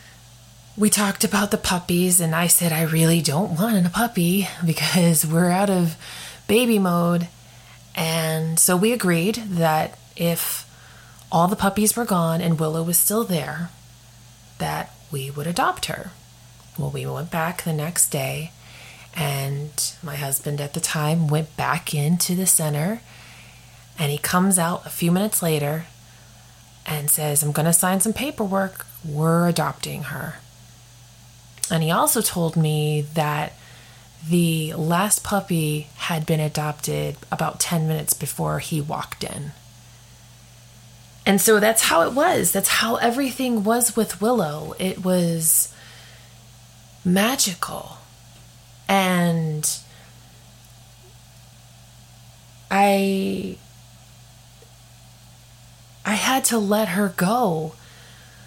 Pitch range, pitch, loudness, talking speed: 125-180 Hz, 160 Hz, -21 LUFS, 125 wpm